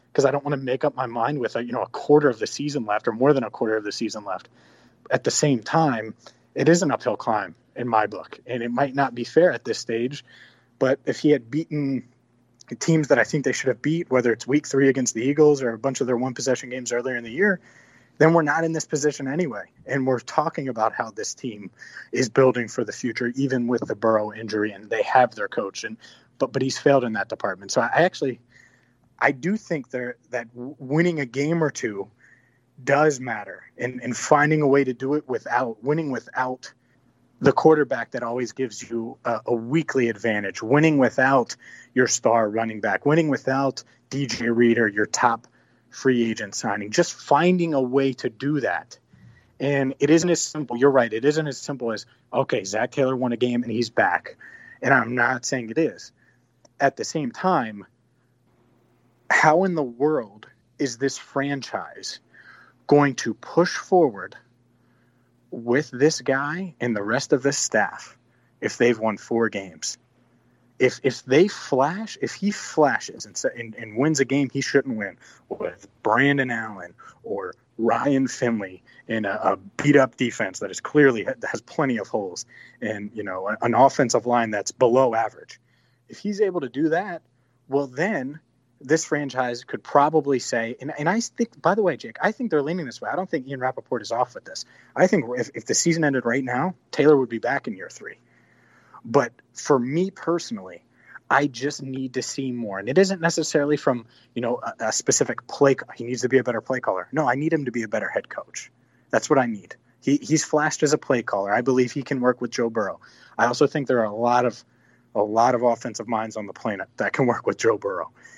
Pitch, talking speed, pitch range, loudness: 130 Hz, 205 wpm, 120-145 Hz, -23 LUFS